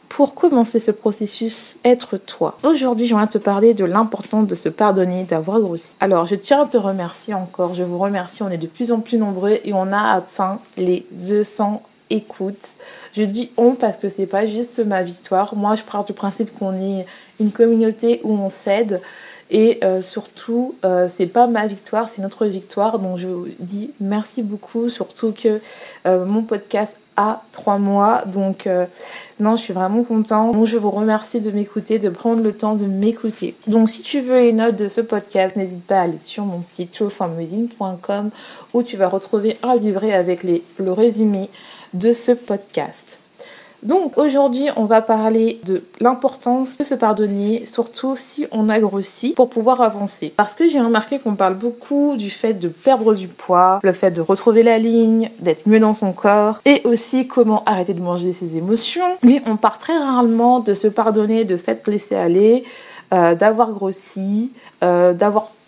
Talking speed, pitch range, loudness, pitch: 185 wpm, 195-230 Hz, -18 LUFS, 215 Hz